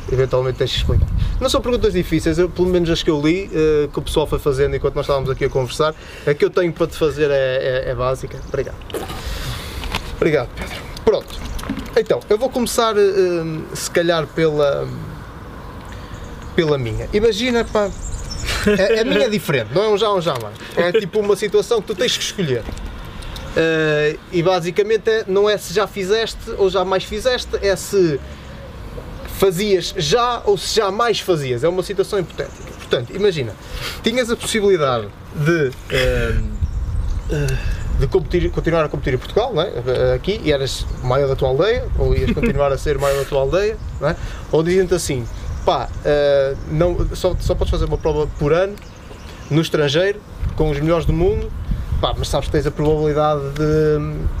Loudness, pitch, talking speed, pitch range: -19 LUFS, 155 Hz, 180 wpm, 130-195 Hz